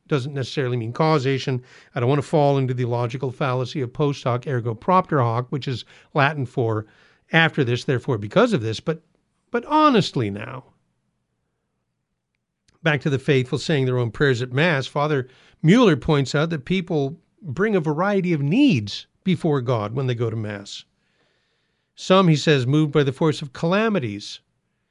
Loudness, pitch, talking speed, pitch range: -21 LUFS, 140 Hz, 170 wpm, 125-160 Hz